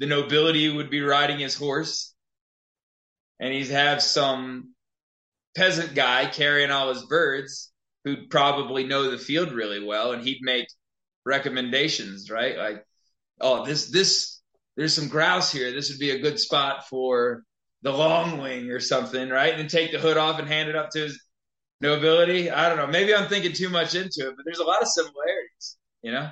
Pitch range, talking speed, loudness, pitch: 130-160 Hz, 185 wpm, -23 LUFS, 145 Hz